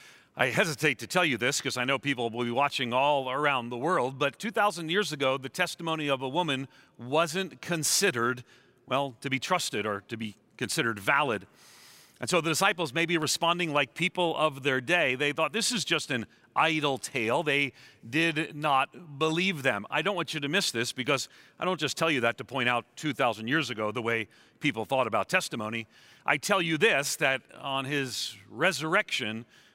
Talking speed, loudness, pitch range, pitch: 195 wpm, -28 LUFS, 125-165 Hz, 140 Hz